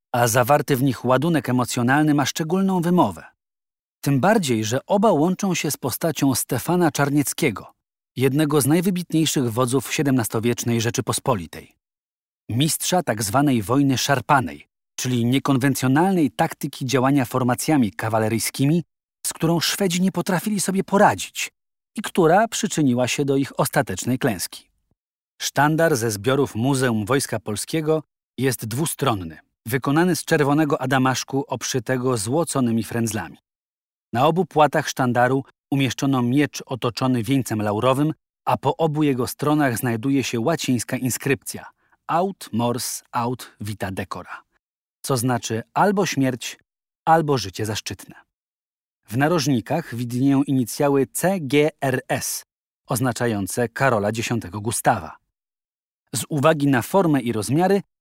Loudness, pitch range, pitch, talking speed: -21 LUFS, 120-150 Hz, 135 Hz, 115 wpm